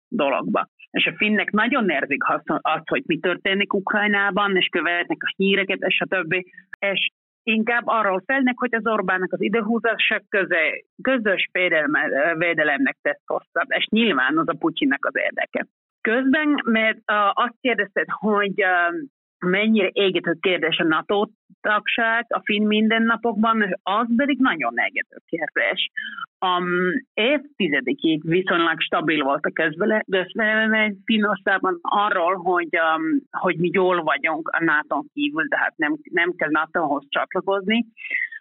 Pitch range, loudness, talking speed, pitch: 185-230 Hz, -21 LUFS, 130 wpm, 205 Hz